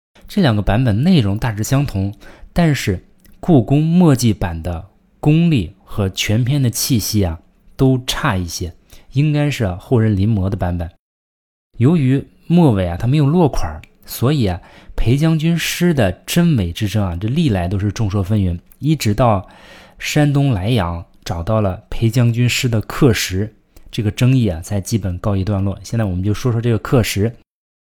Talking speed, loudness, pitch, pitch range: 245 characters per minute, -17 LUFS, 110 Hz, 95-135 Hz